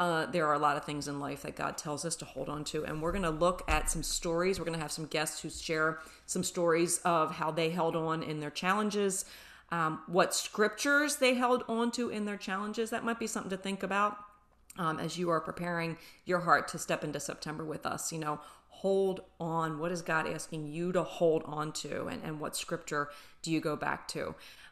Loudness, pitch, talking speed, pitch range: -33 LUFS, 165 Hz, 230 wpm, 155-190 Hz